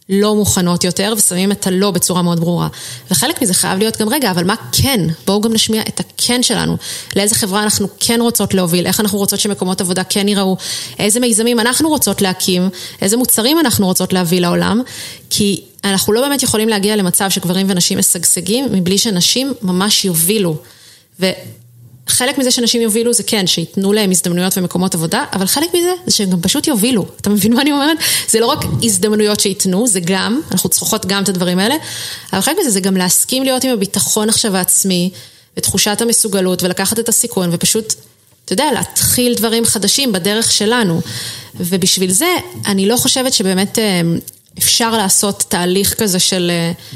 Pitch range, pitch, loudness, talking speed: 185-225 Hz, 200 Hz, -13 LUFS, 175 wpm